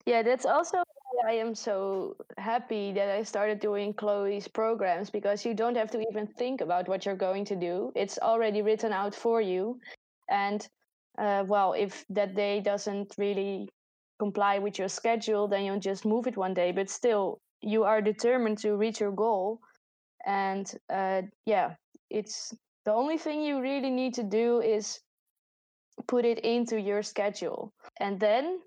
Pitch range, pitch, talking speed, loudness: 200-230 Hz, 210 Hz, 170 wpm, -30 LUFS